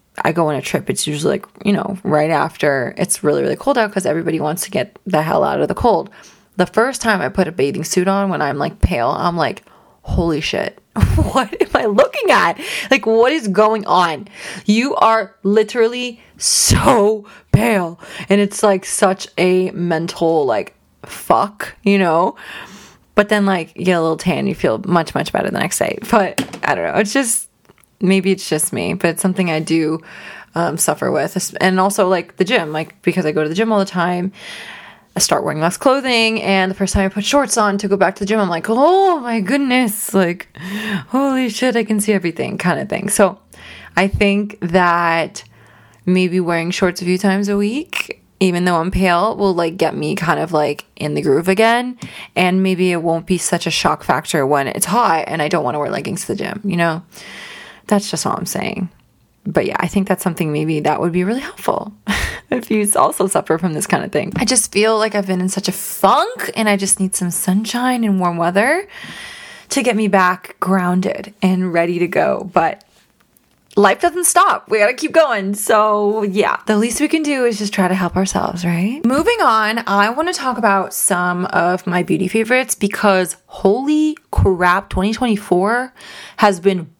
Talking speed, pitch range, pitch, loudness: 205 wpm, 180-220 Hz, 195 Hz, -16 LUFS